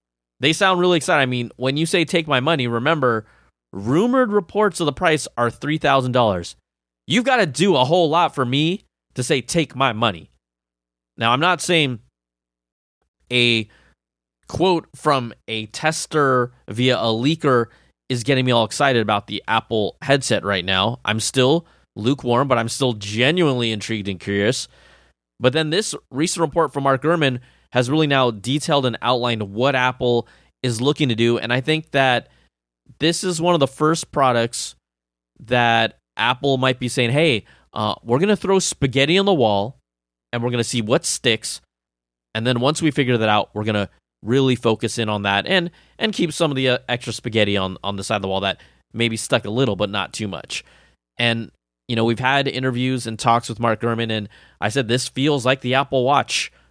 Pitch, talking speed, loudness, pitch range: 120 Hz, 190 wpm, -19 LUFS, 105-140 Hz